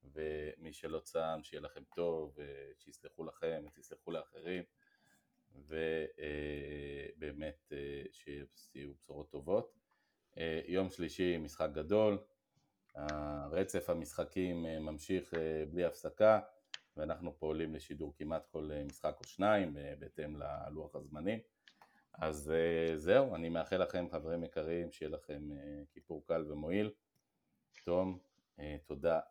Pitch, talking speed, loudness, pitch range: 80 Hz, 100 wpm, -39 LUFS, 75-90 Hz